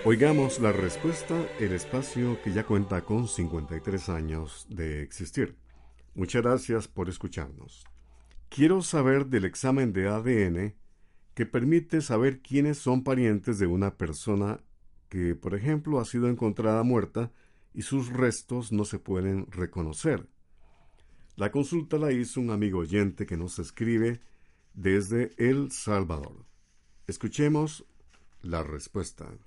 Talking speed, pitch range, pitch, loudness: 125 wpm, 85-125 Hz, 105 Hz, -29 LUFS